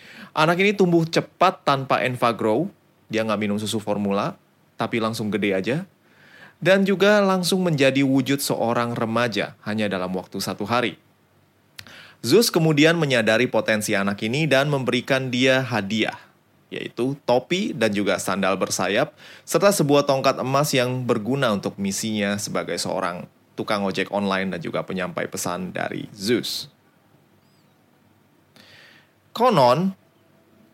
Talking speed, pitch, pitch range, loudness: 125 wpm, 125 Hz, 105-155 Hz, -22 LUFS